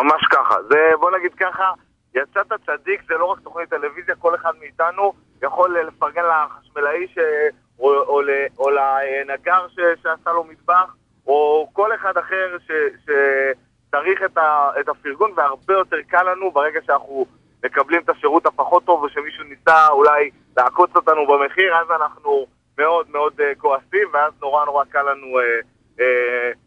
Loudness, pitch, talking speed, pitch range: -18 LUFS, 160 Hz, 140 wpm, 140-185 Hz